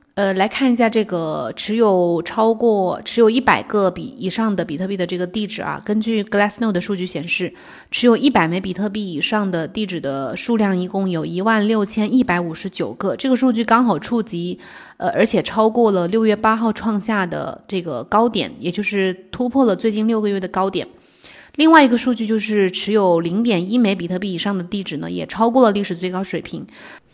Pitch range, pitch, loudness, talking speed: 180-225 Hz, 205 Hz, -18 LUFS, 325 characters per minute